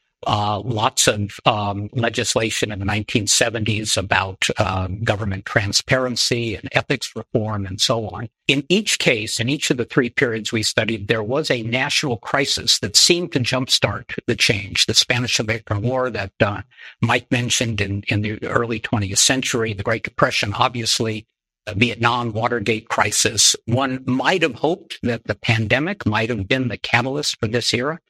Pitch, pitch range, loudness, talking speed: 115 Hz, 105-125 Hz, -19 LUFS, 165 wpm